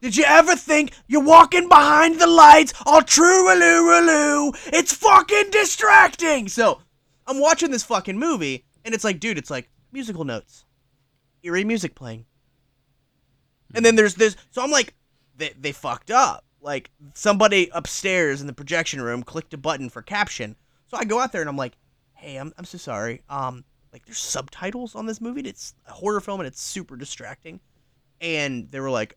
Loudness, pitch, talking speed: -16 LUFS, 190 Hz, 180 wpm